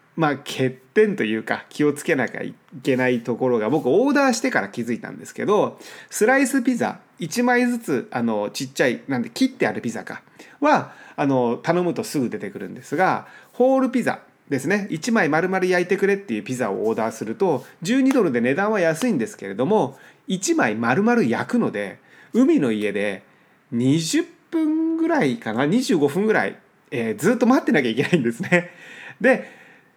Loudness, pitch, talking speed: -21 LUFS, 205 Hz, 330 characters per minute